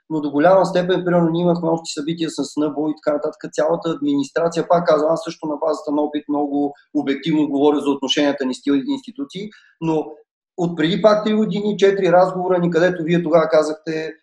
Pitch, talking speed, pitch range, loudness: 160 Hz, 190 wpm, 150-175 Hz, -19 LUFS